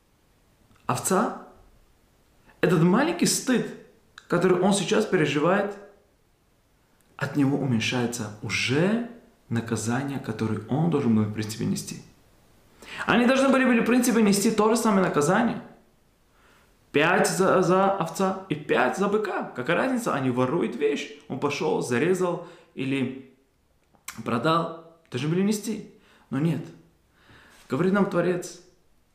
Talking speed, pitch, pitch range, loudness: 115 wpm, 175 Hz, 130-200 Hz, -24 LUFS